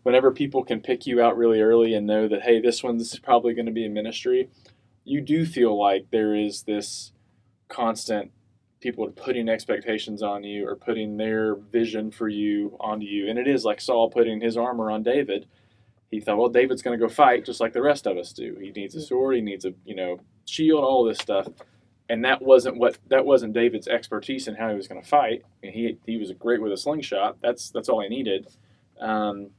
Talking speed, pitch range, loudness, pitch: 225 wpm, 105-120 Hz, -24 LUFS, 115 Hz